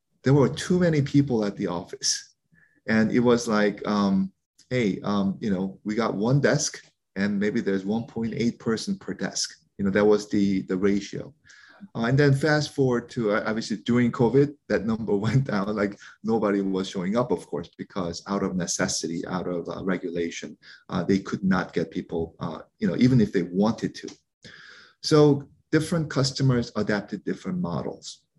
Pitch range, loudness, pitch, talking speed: 100-130 Hz, -25 LUFS, 105 Hz, 180 wpm